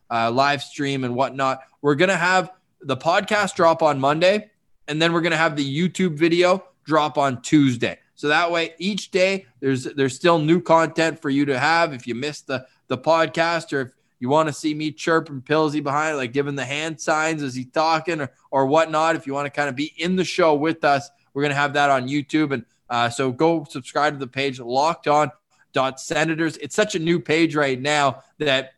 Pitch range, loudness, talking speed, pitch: 140-165 Hz, -21 LUFS, 215 wpm, 150 Hz